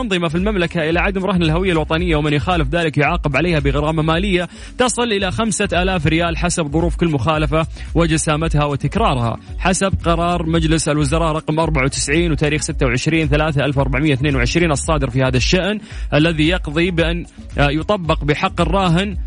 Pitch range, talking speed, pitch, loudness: 150-175 Hz, 150 wpm, 160 Hz, -17 LUFS